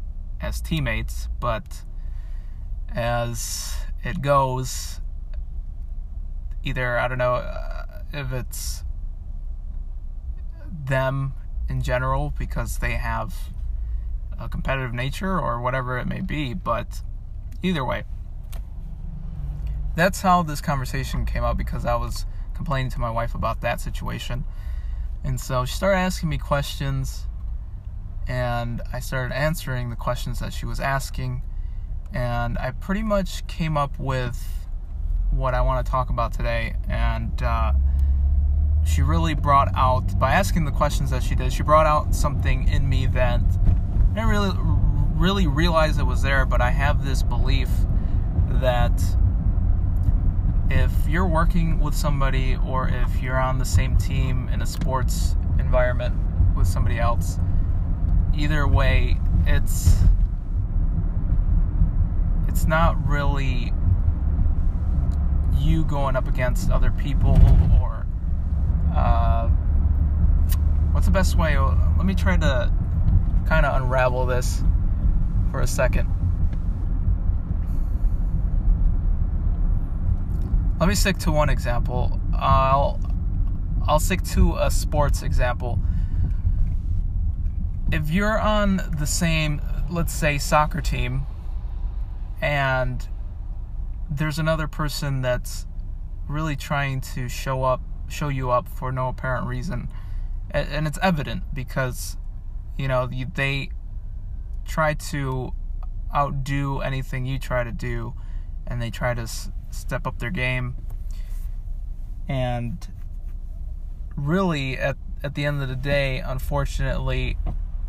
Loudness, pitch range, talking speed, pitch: -24 LUFS, 85-125 Hz, 115 wpm, 90 Hz